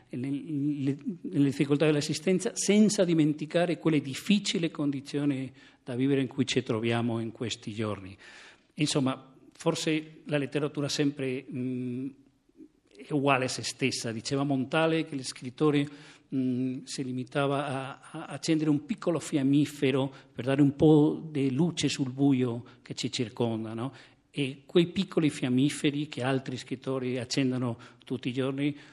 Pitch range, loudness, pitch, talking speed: 130-150 Hz, -29 LUFS, 140 Hz, 135 wpm